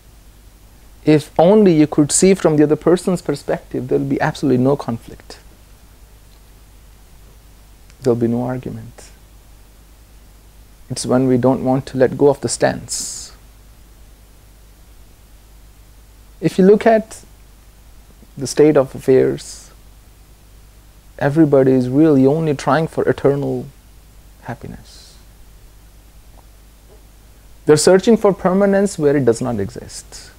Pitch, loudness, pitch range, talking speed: 115 Hz, -15 LUFS, 95-145 Hz, 115 wpm